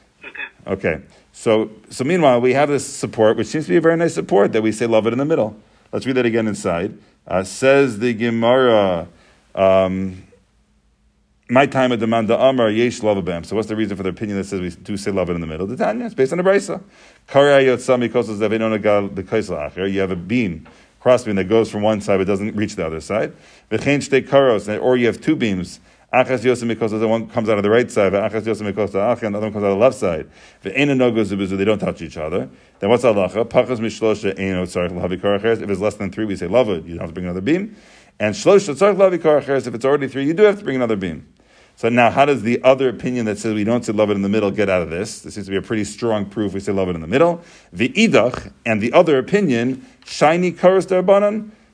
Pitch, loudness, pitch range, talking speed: 110 Hz, -18 LUFS, 100-130 Hz, 225 wpm